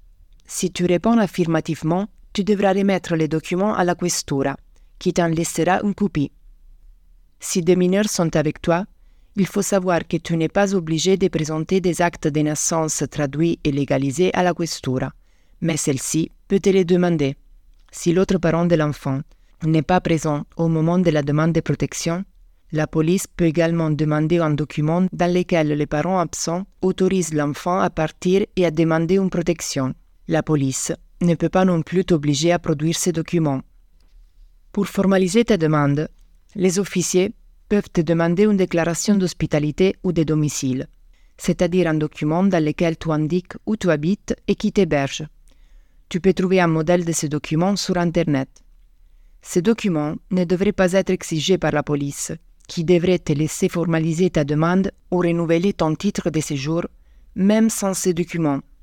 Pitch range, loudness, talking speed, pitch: 150-185 Hz, -20 LUFS, 165 wpm, 170 Hz